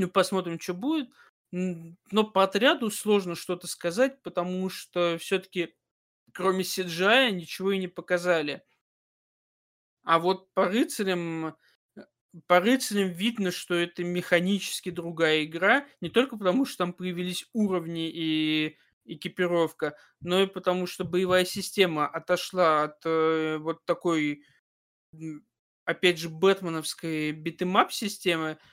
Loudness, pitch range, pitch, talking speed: -27 LUFS, 165-190 Hz, 180 Hz, 115 wpm